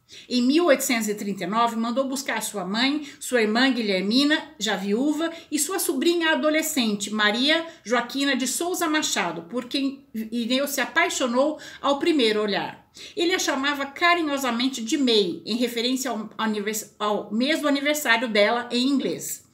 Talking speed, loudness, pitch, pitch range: 135 wpm, -23 LUFS, 260 Hz, 225-300 Hz